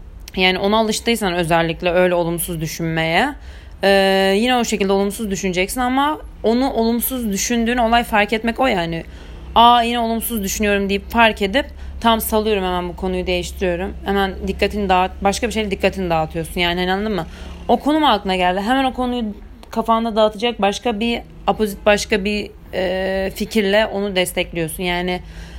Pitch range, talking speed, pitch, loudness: 185-230 Hz, 155 wpm, 200 Hz, -18 LUFS